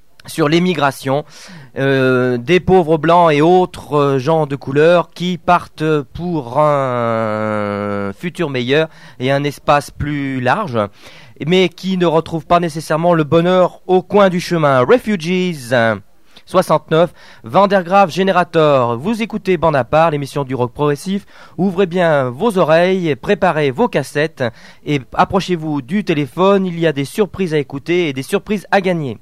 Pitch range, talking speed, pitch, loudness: 140-180 Hz, 145 wpm, 160 Hz, -15 LUFS